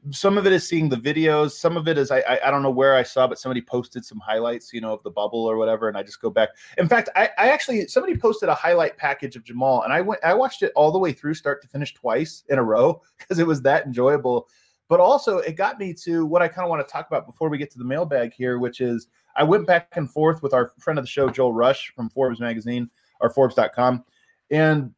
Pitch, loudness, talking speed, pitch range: 135 Hz, -21 LUFS, 265 wpm, 125-165 Hz